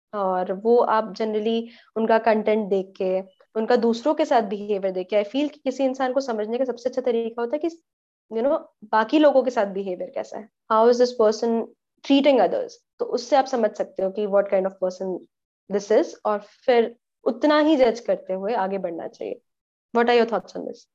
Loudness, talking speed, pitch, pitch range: -23 LUFS, 210 wpm, 230 Hz, 205-260 Hz